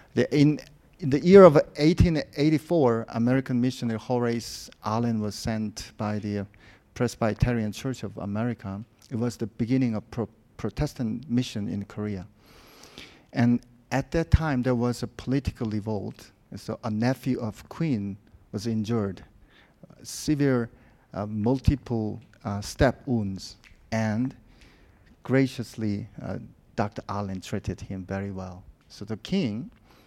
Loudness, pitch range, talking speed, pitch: -26 LUFS, 105-125 Hz, 130 wpm, 115 Hz